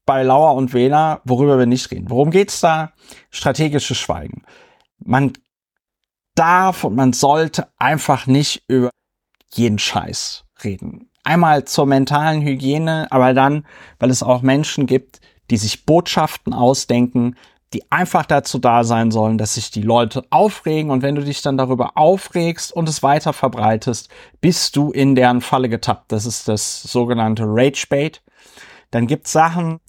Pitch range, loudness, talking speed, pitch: 125-155 Hz, -16 LUFS, 155 wpm, 135 Hz